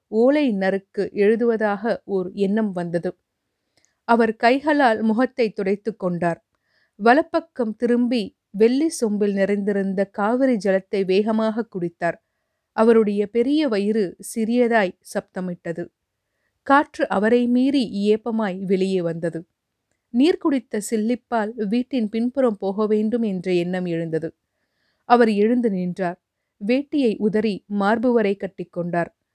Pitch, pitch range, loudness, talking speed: 215 Hz, 195-240 Hz, -21 LUFS, 100 wpm